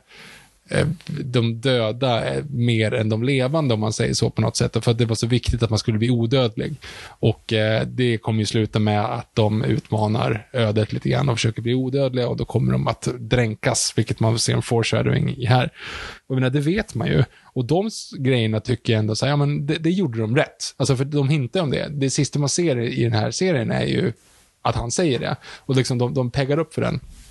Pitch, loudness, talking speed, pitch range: 125 Hz, -21 LUFS, 225 wpm, 115-140 Hz